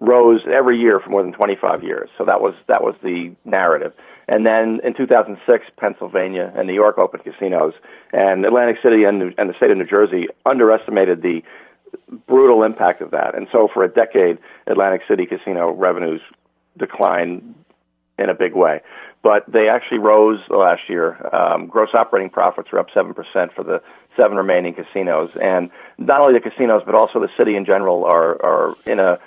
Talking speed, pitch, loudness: 185 wpm, 110 Hz, -16 LUFS